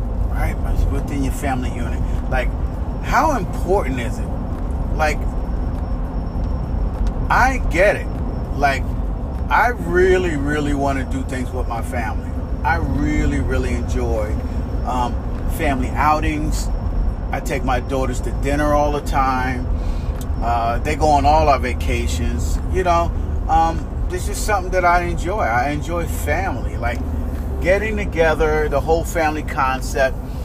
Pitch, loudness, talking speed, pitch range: 80 Hz, -20 LUFS, 130 wpm, 75-90 Hz